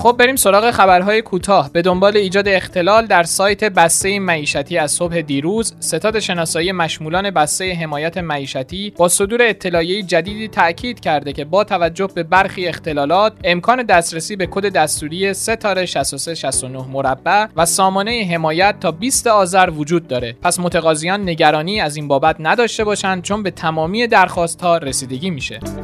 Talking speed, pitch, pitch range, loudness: 150 wpm, 180 Hz, 160-200 Hz, -15 LUFS